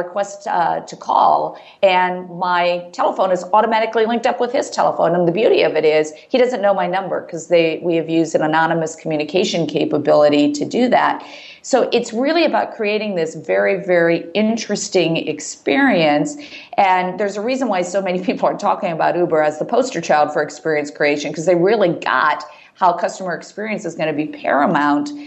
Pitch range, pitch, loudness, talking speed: 155-210 Hz, 175 Hz, -17 LUFS, 185 wpm